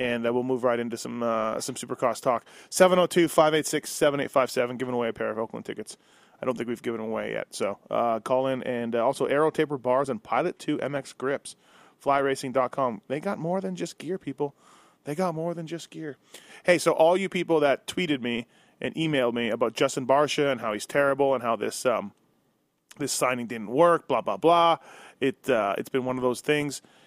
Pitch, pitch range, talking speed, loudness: 135 Hz, 120-160 Hz, 210 wpm, -26 LUFS